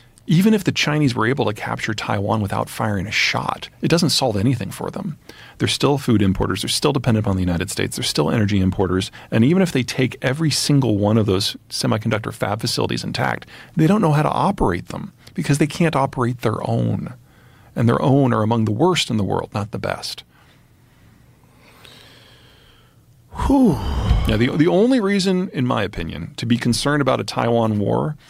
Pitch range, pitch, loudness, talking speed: 110-145 Hz, 120 Hz, -19 LUFS, 190 wpm